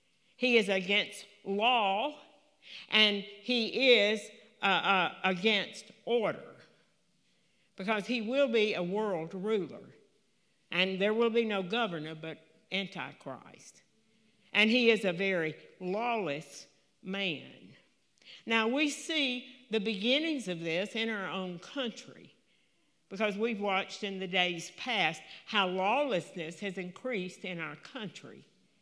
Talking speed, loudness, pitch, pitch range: 120 wpm, -31 LUFS, 205 Hz, 185-230 Hz